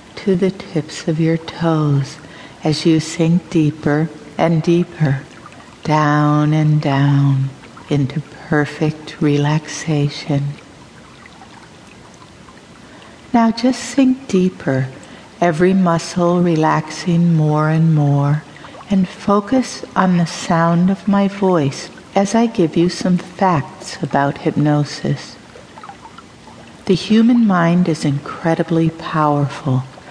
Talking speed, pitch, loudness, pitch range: 100 wpm, 160 Hz, -16 LUFS, 150-180 Hz